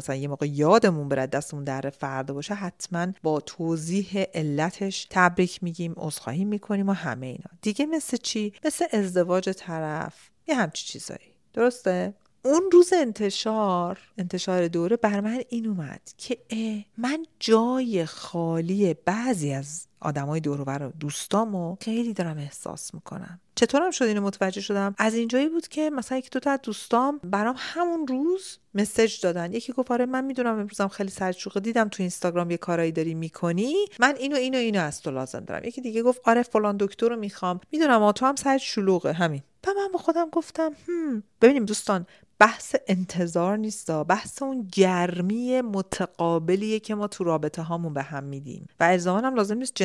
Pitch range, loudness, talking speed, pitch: 170-240 Hz, -25 LUFS, 170 wpm, 200 Hz